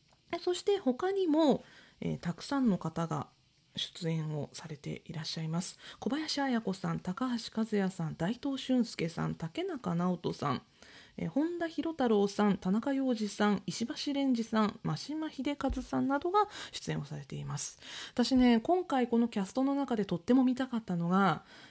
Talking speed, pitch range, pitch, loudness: 320 characters per minute, 175-275 Hz, 225 Hz, -33 LUFS